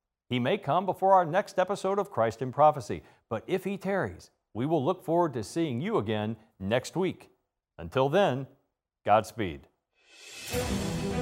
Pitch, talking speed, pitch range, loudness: 135 Hz, 150 wpm, 110-185 Hz, -29 LUFS